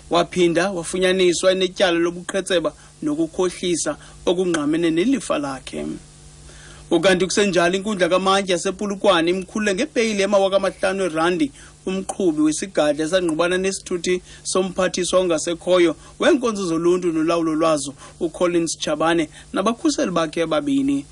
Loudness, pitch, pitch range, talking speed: -20 LUFS, 185 Hz, 170-200 Hz, 90 wpm